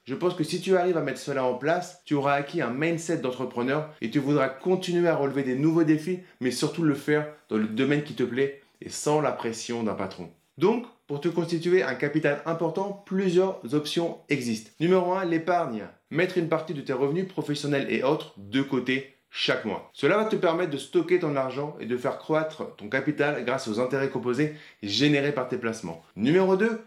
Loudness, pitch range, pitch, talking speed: -27 LUFS, 130-170 Hz, 145 Hz, 205 wpm